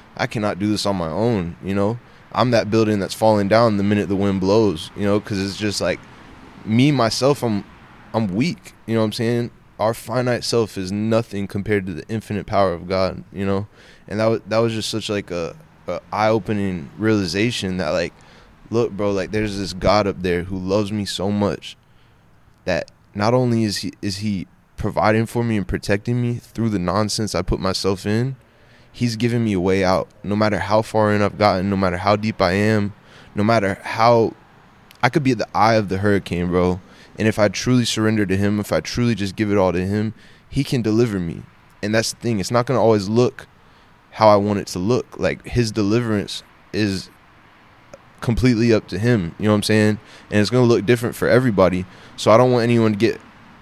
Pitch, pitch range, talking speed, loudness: 105 Hz, 100-115 Hz, 215 wpm, -20 LUFS